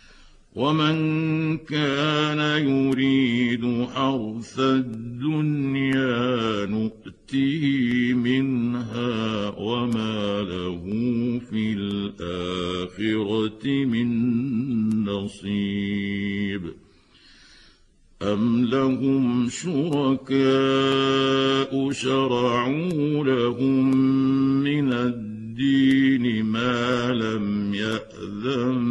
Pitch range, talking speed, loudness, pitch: 110-135 Hz, 50 wpm, -23 LUFS, 125 Hz